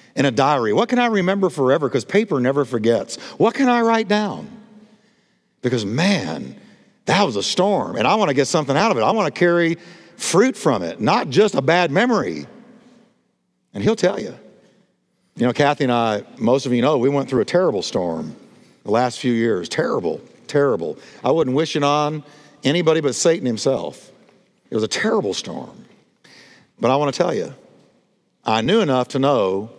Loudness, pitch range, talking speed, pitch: -19 LUFS, 130-200 Hz, 190 wpm, 150 Hz